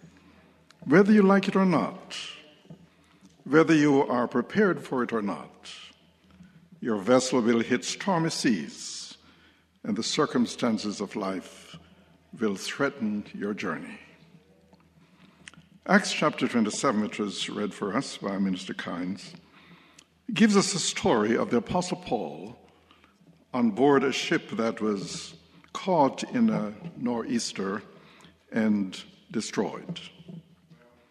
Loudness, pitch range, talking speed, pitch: -26 LUFS, 115-185 Hz, 115 wpm, 150 Hz